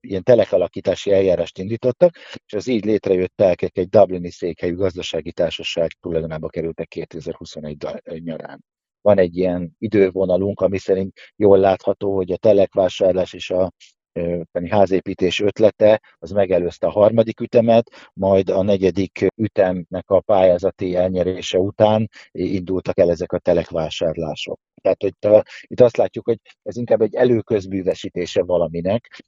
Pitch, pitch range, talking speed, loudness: 95 Hz, 90-105 Hz, 130 wpm, -19 LUFS